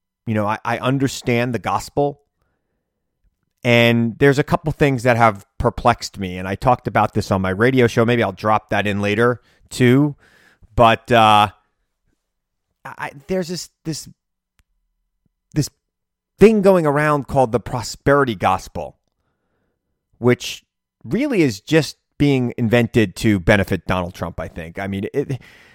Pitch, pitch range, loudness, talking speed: 115 Hz, 100-140 Hz, -18 LUFS, 140 wpm